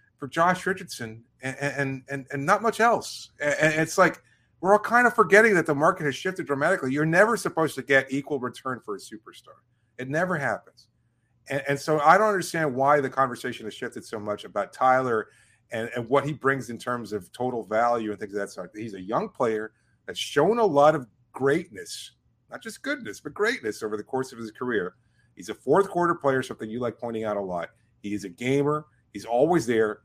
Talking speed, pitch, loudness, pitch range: 215 wpm, 135 Hz, -25 LUFS, 120-160 Hz